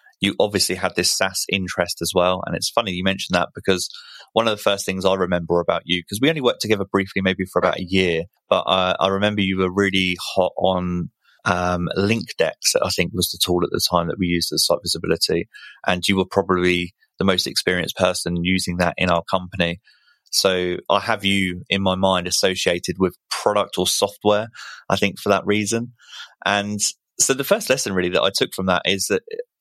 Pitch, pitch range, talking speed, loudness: 95 Hz, 90-100 Hz, 210 wpm, -20 LUFS